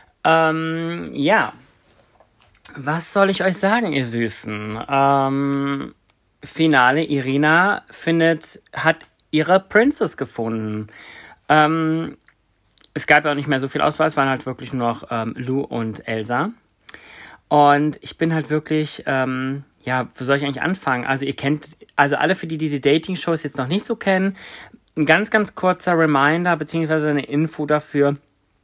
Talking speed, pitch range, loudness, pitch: 155 wpm, 135-160 Hz, -19 LUFS, 150 Hz